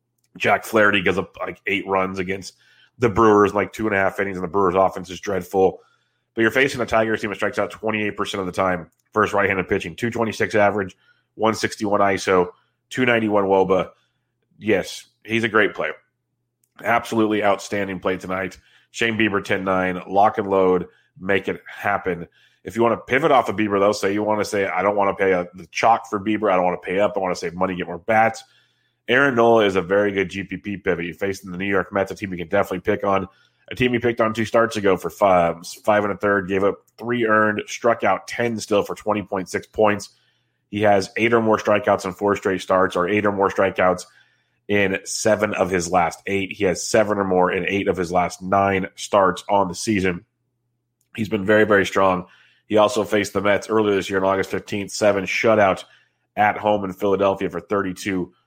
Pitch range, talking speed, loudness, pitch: 95-110 Hz, 215 wpm, -20 LUFS, 100 Hz